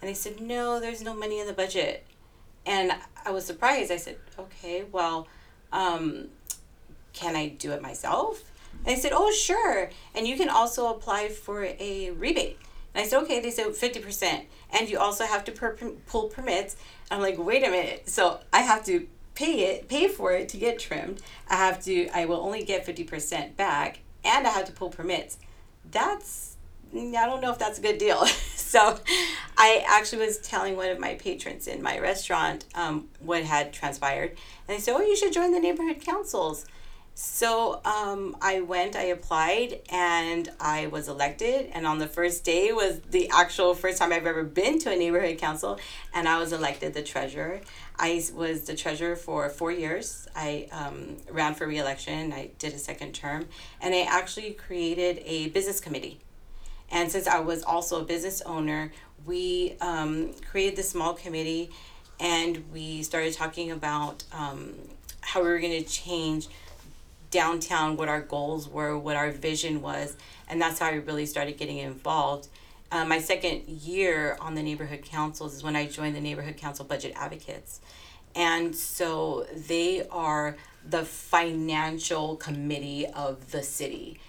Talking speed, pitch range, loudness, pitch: 175 wpm, 155-205 Hz, -28 LUFS, 170 Hz